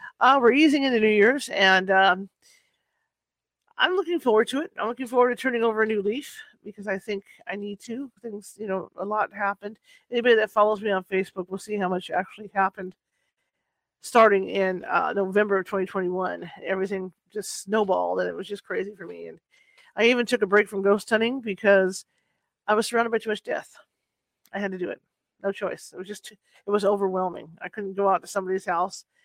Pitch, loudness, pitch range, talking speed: 205 Hz, -24 LUFS, 190-230 Hz, 200 wpm